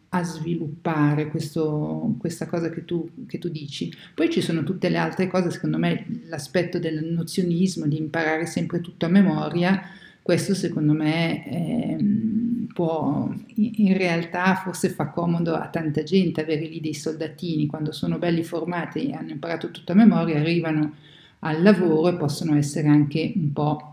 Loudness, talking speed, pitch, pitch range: -24 LUFS, 160 wpm, 165 Hz, 155-180 Hz